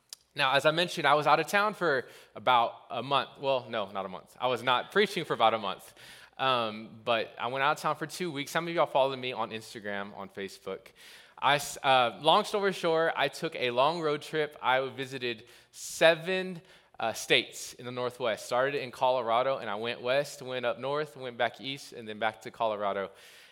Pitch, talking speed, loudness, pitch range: 130 Hz, 210 wpm, -29 LUFS, 115-160 Hz